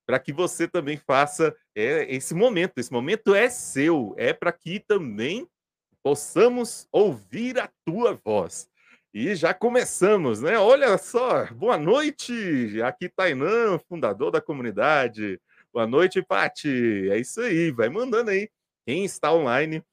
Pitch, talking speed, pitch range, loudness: 180 Hz, 140 wpm, 145-240 Hz, -23 LUFS